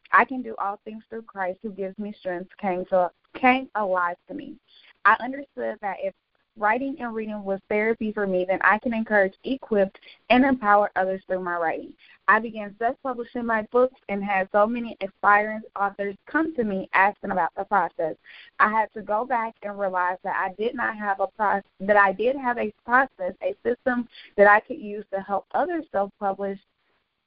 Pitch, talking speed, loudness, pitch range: 205 Hz, 190 wpm, -24 LUFS, 195-235 Hz